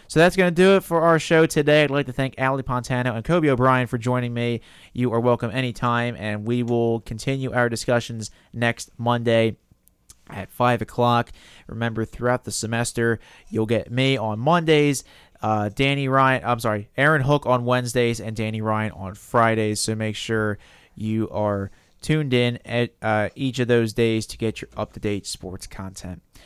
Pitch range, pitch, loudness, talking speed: 110-130 Hz, 120 Hz, -22 LUFS, 175 wpm